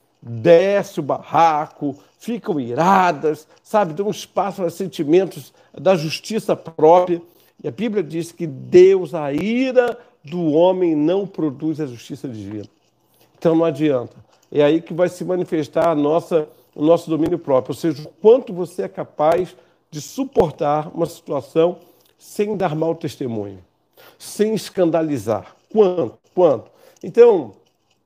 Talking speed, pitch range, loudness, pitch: 135 wpm, 150-185 Hz, -19 LUFS, 165 Hz